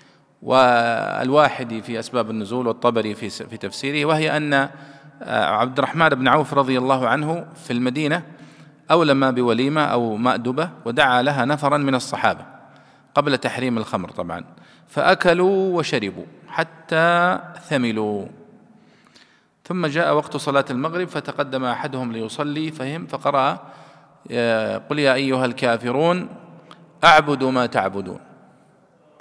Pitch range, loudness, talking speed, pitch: 120-150 Hz, -20 LUFS, 110 wpm, 135 Hz